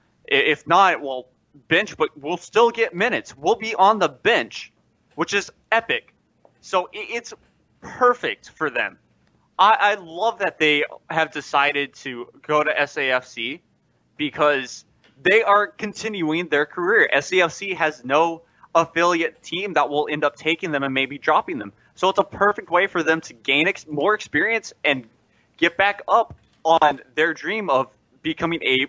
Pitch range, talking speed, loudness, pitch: 145-200 Hz, 155 wpm, -21 LUFS, 160 Hz